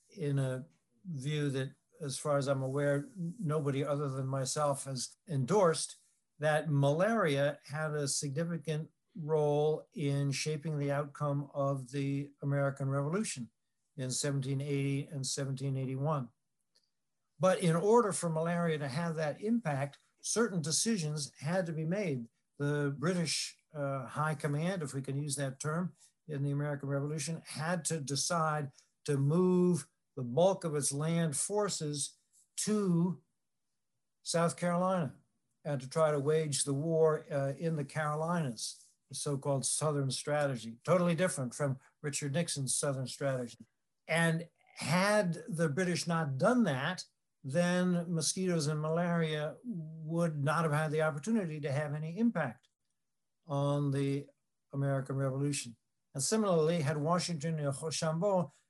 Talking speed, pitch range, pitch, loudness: 135 wpm, 140-170 Hz, 150 Hz, -34 LUFS